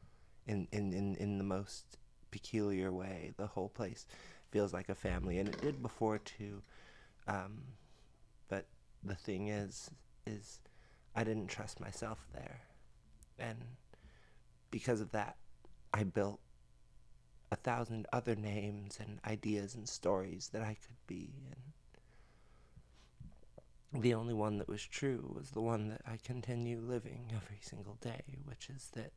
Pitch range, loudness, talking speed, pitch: 95-115 Hz, -42 LUFS, 140 wpm, 105 Hz